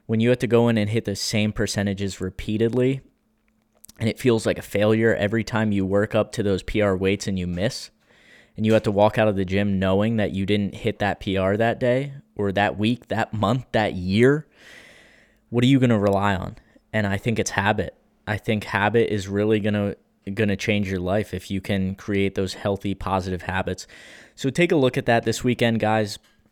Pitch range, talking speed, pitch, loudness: 100-115 Hz, 215 wpm, 105 Hz, -22 LUFS